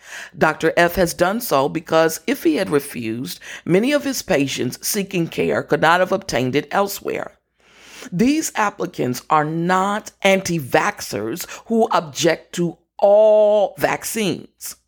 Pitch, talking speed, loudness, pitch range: 175 Hz, 135 wpm, -19 LUFS, 155-205 Hz